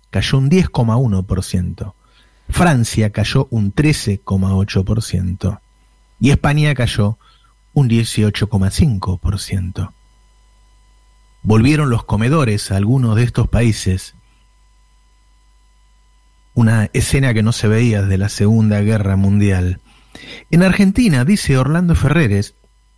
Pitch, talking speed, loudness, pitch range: 105 Hz, 95 wpm, -15 LUFS, 95-120 Hz